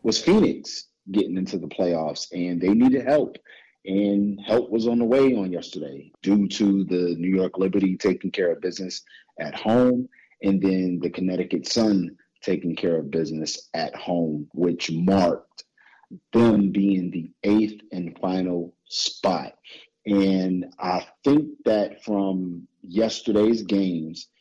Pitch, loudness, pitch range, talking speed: 95 Hz, -23 LUFS, 90-105 Hz, 140 wpm